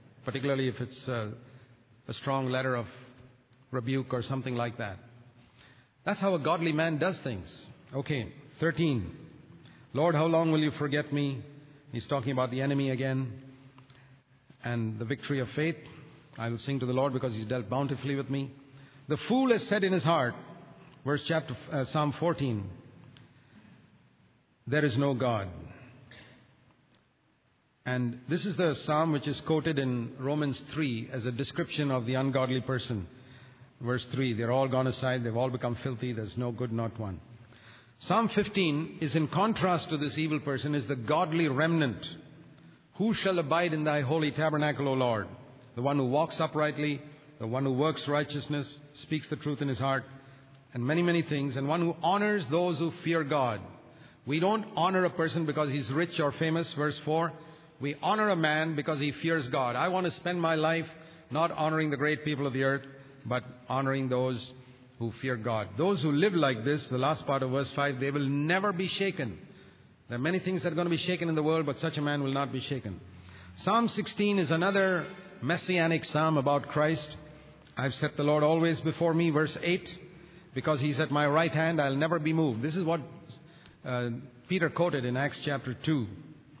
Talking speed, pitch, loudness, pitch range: 185 wpm, 145 Hz, -30 LUFS, 130-160 Hz